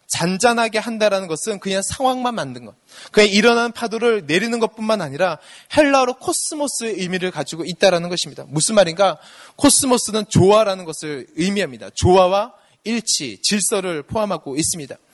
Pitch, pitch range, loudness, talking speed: 205 Hz, 180-230 Hz, -18 LUFS, 370 characters per minute